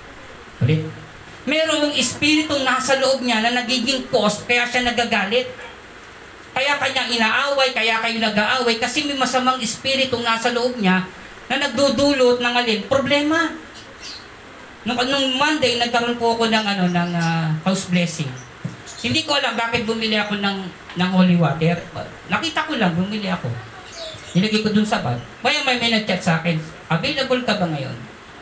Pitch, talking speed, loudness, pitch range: 235 Hz, 155 wpm, -19 LUFS, 185-260 Hz